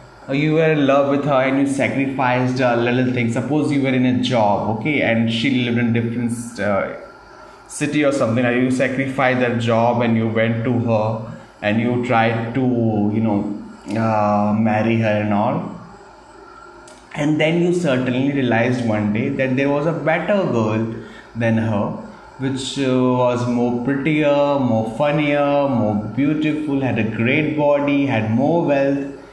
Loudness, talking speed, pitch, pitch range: -18 LUFS, 160 wpm, 125 Hz, 115-140 Hz